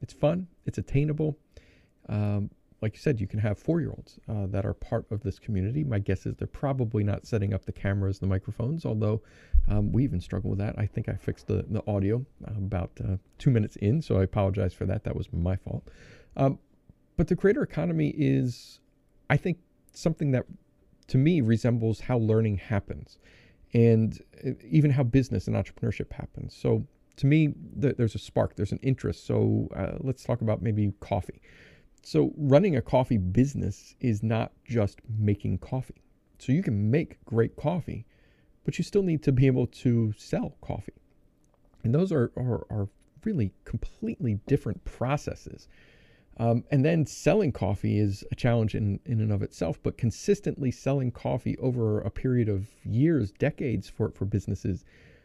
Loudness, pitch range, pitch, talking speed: -28 LUFS, 100-135 Hz, 115 Hz, 175 wpm